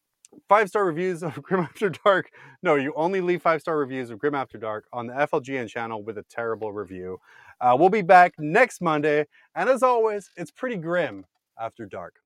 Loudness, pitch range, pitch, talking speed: -23 LUFS, 115-180 Hz, 150 Hz, 195 wpm